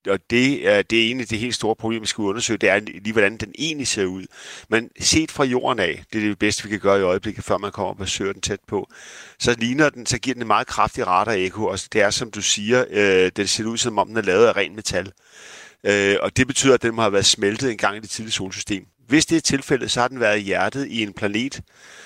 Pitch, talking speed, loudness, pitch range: 110 Hz, 270 wpm, -20 LUFS, 100-125 Hz